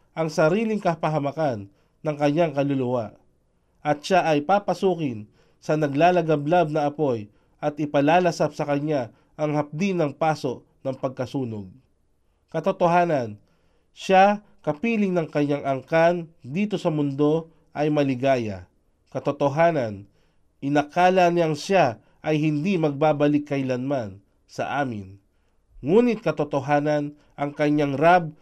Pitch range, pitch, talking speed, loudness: 130-165 Hz, 150 Hz, 105 wpm, -23 LUFS